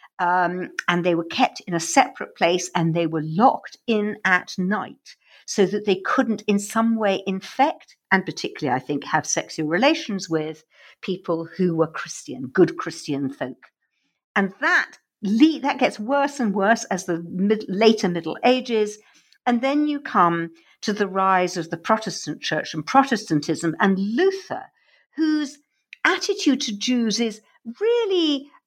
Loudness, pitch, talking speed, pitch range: -22 LUFS, 200 Hz, 155 wpm, 170-250 Hz